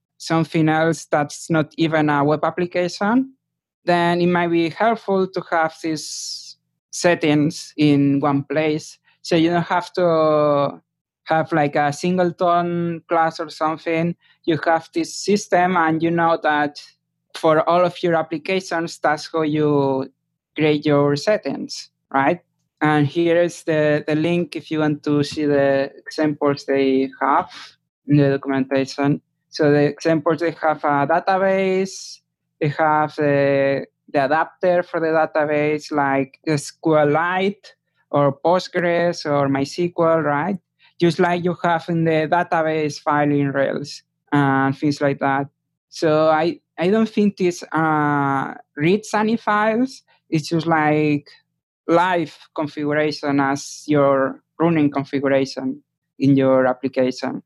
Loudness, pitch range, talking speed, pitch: -19 LUFS, 145-170 Hz, 135 wpm, 155 Hz